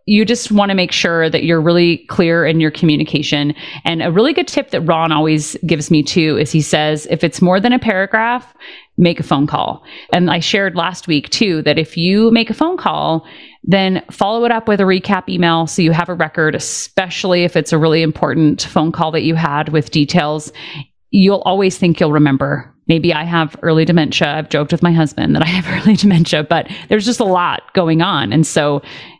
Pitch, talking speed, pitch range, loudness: 170 Hz, 215 wpm, 155-195 Hz, -14 LUFS